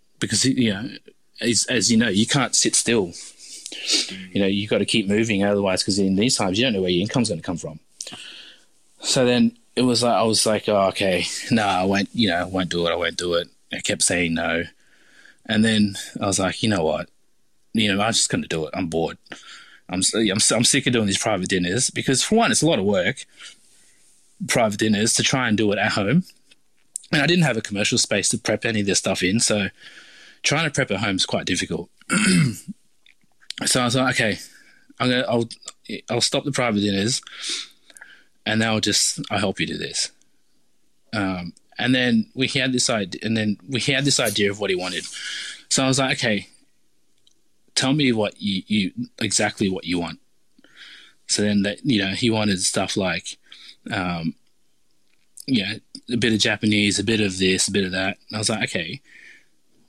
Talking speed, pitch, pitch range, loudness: 210 wpm, 110 Hz, 95-125 Hz, -21 LUFS